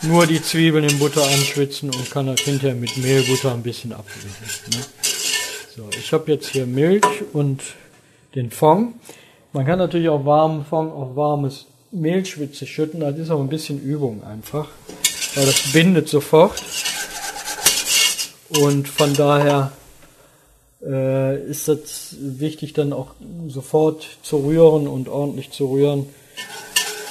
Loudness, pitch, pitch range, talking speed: -19 LUFS, 145 Hz, 135-155 Hz, 135 wpm